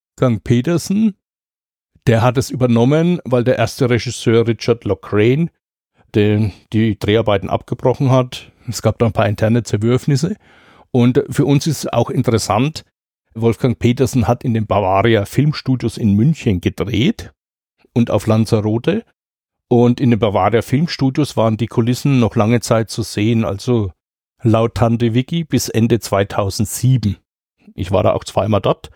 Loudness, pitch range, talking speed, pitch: -16 LUFS, 110-130 Hz, 145 wpm, 120 Hz